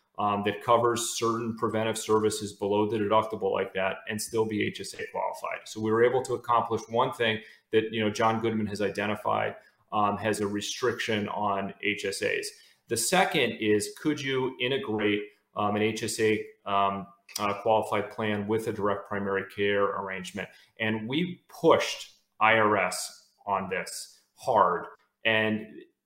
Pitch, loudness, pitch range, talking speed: 110 Hz, -28 LUFS, 105-115 Hz, 145 wpm